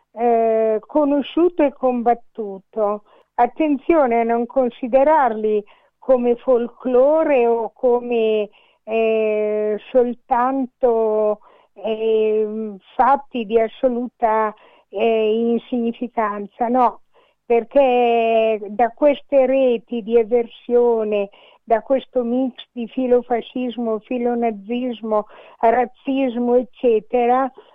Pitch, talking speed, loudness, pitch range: 240 Hz, 75 wpm, -19 LUFS, 220-255 Hz